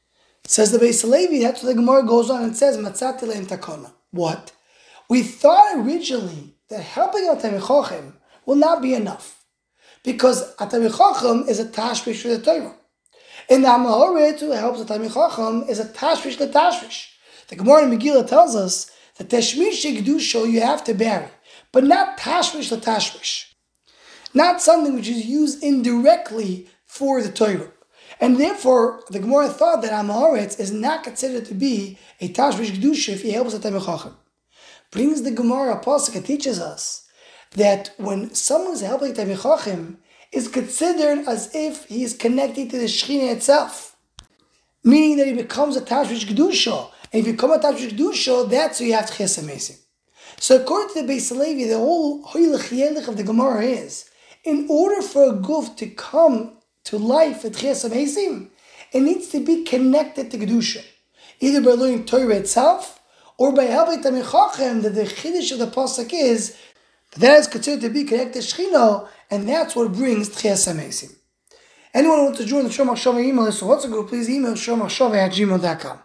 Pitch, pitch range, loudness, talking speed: 255 Hz, 225-295 Hz, -19 LUFS, 165 wpm